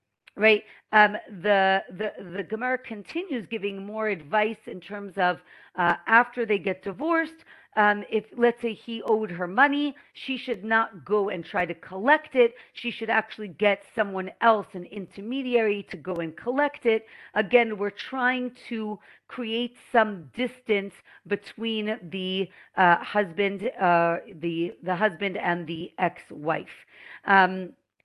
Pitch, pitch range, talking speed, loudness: 210 Hz, 190-235 Hz, 145 wpm, -26 LUFS